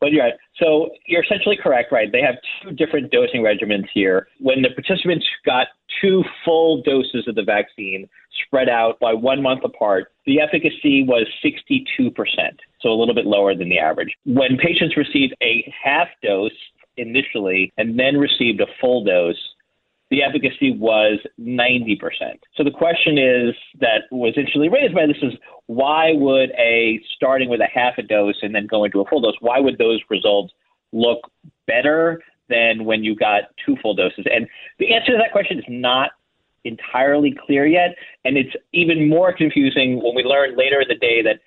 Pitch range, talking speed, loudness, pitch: 115-165 Hz, 180 wpm, -18 LUFS, 135 Hz